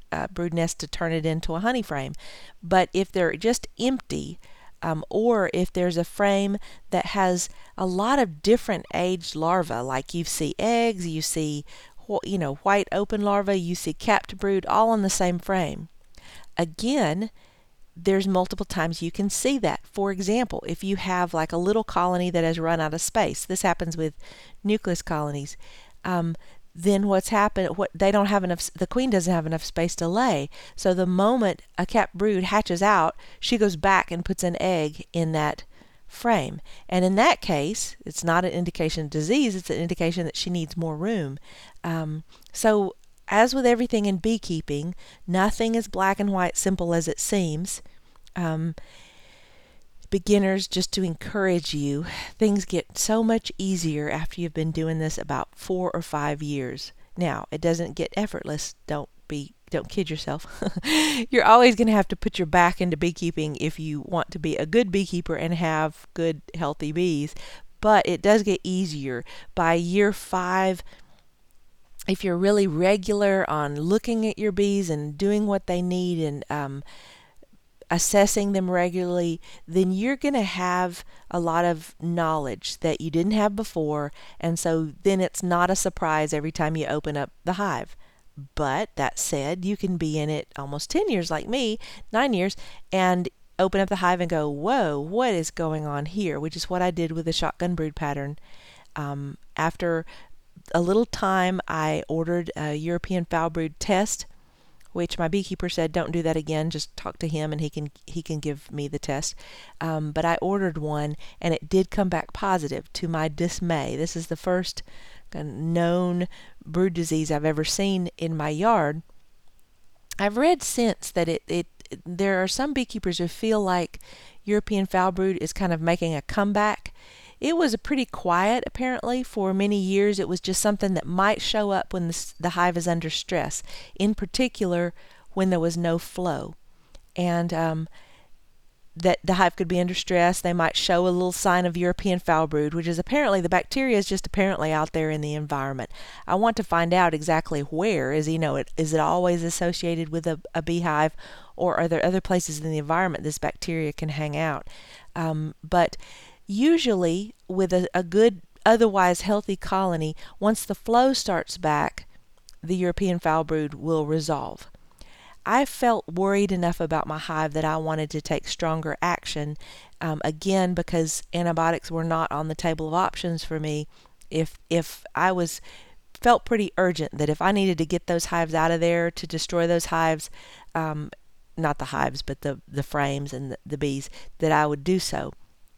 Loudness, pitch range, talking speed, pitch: -25 LUFS, 160-195 Hz, 180 wpm, 175 Hz